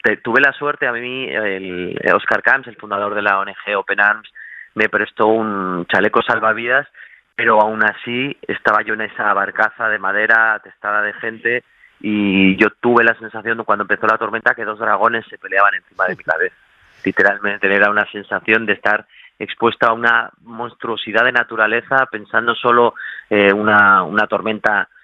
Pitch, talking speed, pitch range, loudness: 110 Hz, 170 wpm, 105-115 Hz, -16 LUFS